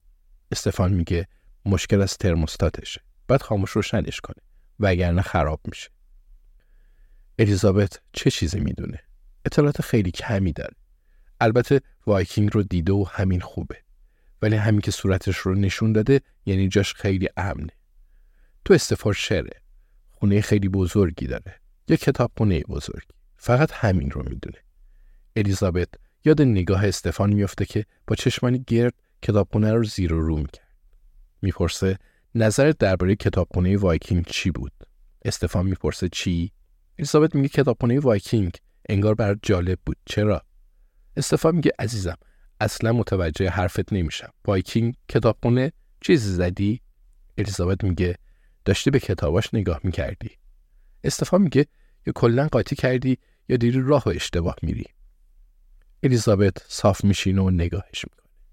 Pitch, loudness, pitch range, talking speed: 100 Hz, -23 LUFS, 90-115 Hz, 125 wpm